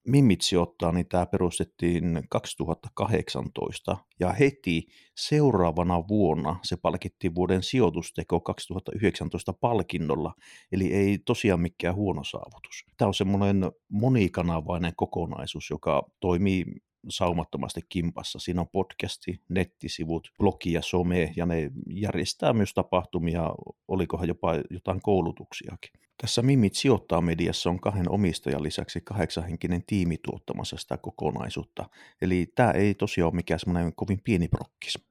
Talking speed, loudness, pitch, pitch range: 120 wpm, -28 LUFS, 90 Hz, 85-100 Hz